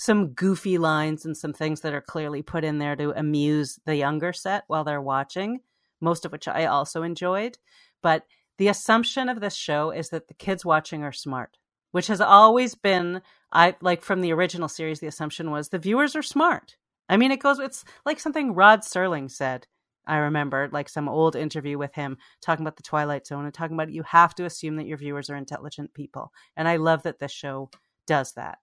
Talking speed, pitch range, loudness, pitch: 210 wpm, 150-190 Hz, -24 LUFS, 160 Hz